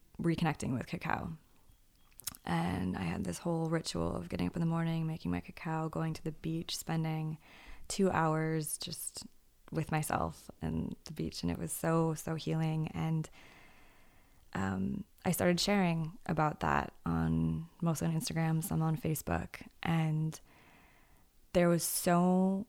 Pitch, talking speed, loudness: 160 Hz, 145 wpm, -35 LUFS